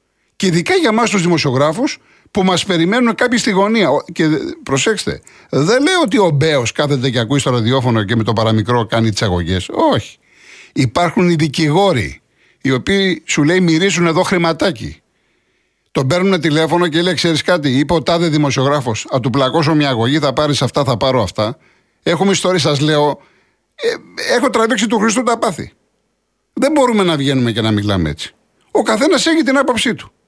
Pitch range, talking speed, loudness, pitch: 135-195 Hz, 175 wpm, -14 LUFS, 160 Hz